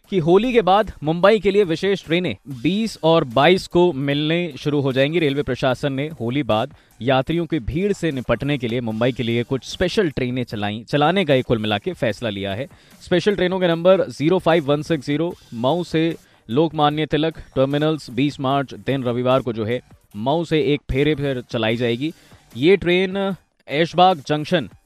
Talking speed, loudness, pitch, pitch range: 175 wpm, -20 LUFS, 150 Hz, 125-170 Hz